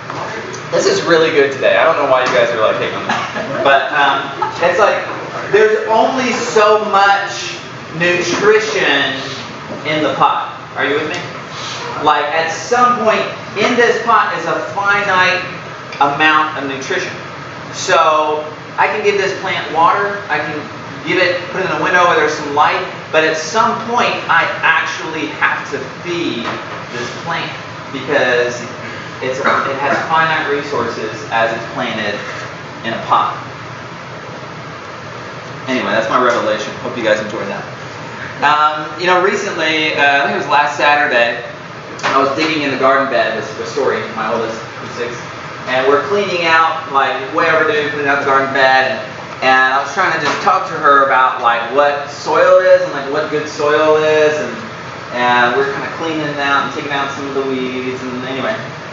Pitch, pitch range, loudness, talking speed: 155 Hz, 140-185 Hz, -14 LUFS, 175 wpm